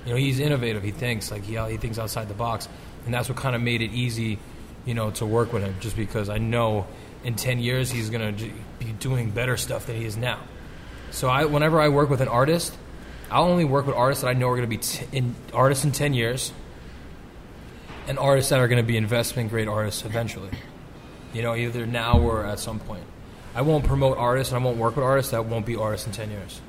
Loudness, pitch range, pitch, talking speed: -24 LUFS, 110-125 Hz, 115 Hz, 240 wpm